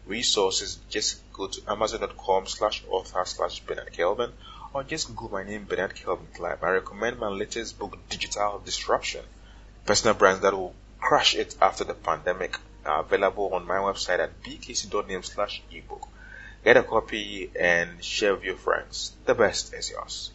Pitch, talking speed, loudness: 380 Hz, 160 wpm, -26 LUFS